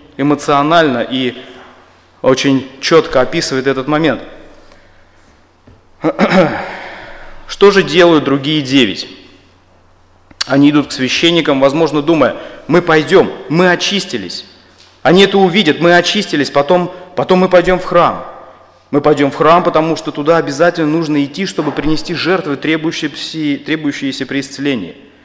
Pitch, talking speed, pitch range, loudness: 150 Hz, 115 wpm, 130-170 Hz, -12 LUFS